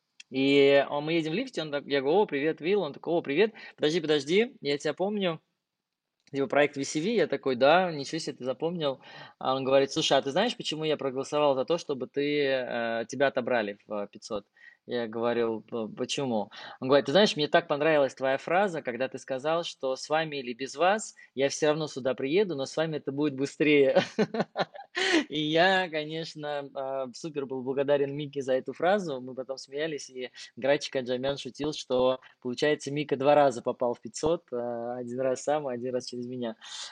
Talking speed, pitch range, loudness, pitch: 185 wpm, 130-155 Hz, -28 LUFS, 140 Hz